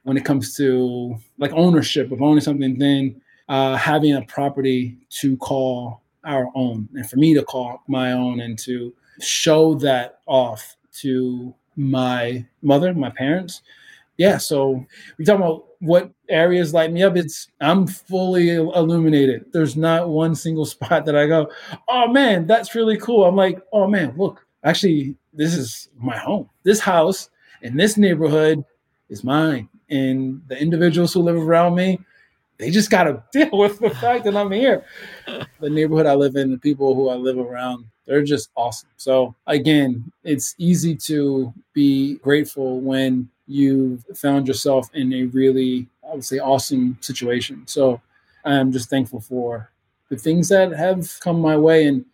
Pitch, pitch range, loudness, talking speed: 145 Hz, 130-170 Hz, -19 LUFS, 165 wpm